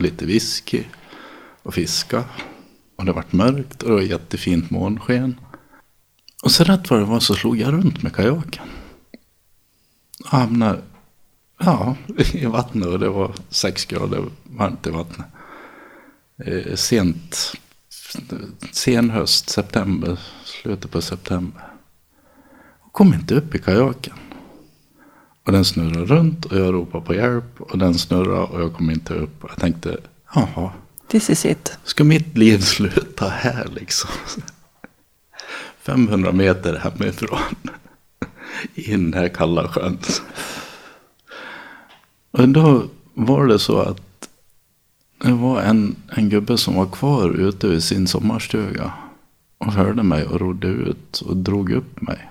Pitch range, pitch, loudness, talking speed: 90-125 Hz, 100 Hz, -19 LUFS, 135 wpm